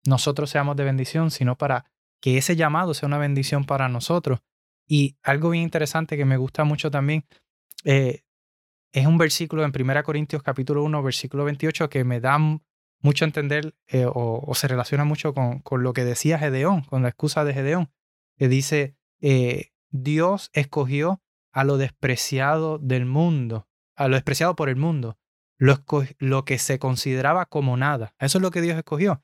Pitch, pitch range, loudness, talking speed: 145 Hz, 130-155 Hz, -23 LUFS, 180 wpm